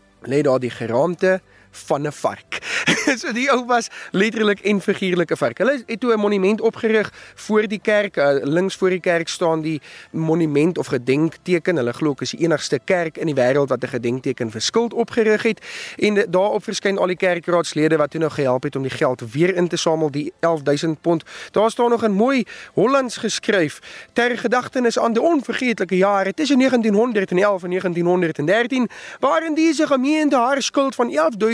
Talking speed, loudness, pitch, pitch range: 180 wpm, -19 LUFS, 190 Hz, 160-230 Hz